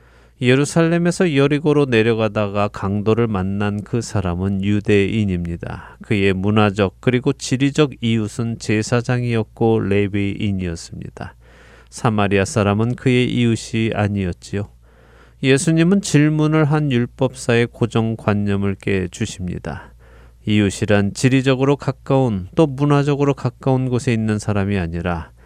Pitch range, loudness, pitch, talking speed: 100-130 Hz, -18 LUFS, 110 Hz, 300 characters per minute